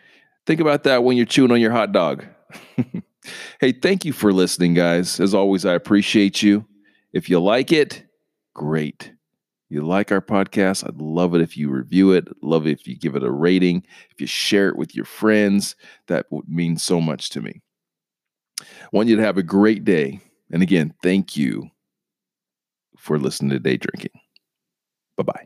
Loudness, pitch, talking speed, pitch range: -19 LUFS, 95 Hz, 185 wpm, 85-110 Hz